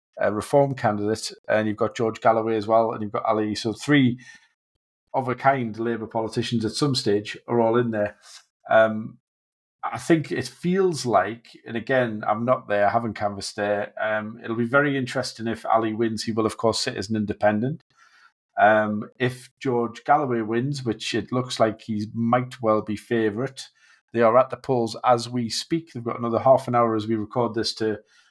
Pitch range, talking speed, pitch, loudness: 110-125 Hz, 195 wpm, 115 Hz, -23 LUFS